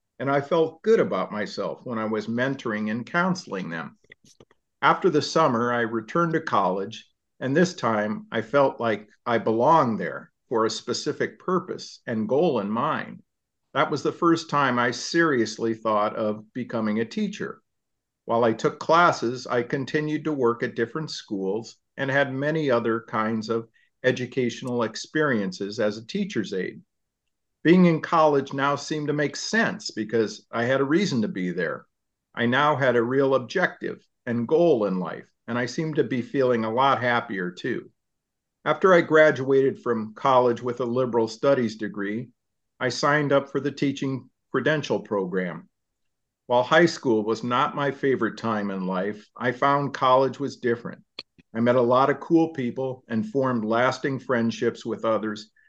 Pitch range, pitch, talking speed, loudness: 115-145 Hz, 125 Hz, 165 wpm, -24 LUFS